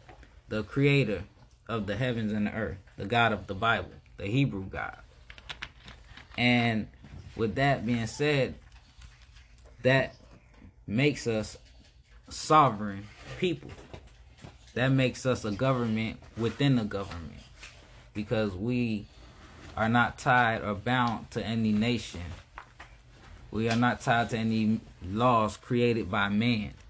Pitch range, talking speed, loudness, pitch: 100-120 Hz, 120 wpm, -28 LUFS, 110 Hz